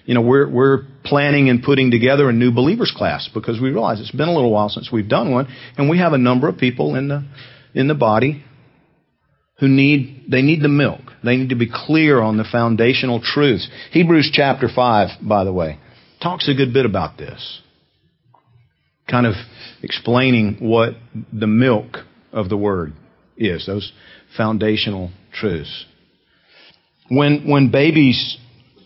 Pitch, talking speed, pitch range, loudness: 125 Hz, 165 wpm, 110-140 Hz, -16 LUFS